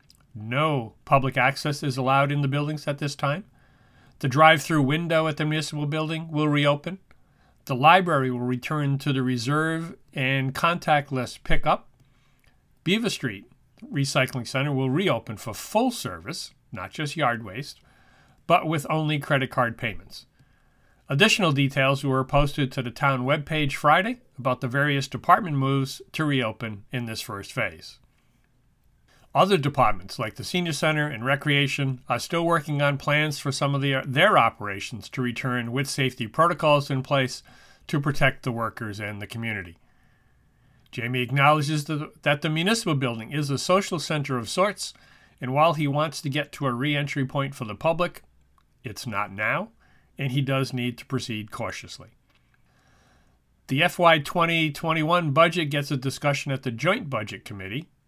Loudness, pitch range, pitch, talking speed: -24 LUFS, 125-155 Hz, 140 Hz, 160 wpm